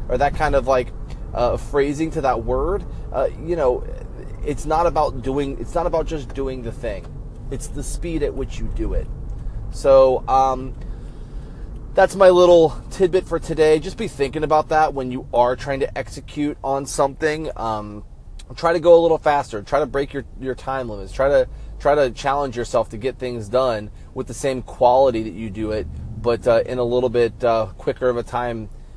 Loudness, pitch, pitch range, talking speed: -20 LUFS, 130 Hz, 120-150 Hz, 200 wpm